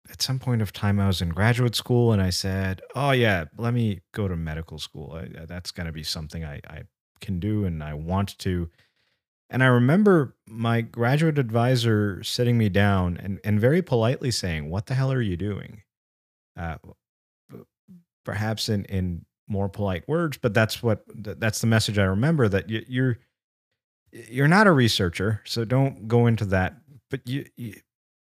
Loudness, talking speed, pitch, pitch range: -24 LUFS, 180 wpm, 110 Hz, 95-125 Hz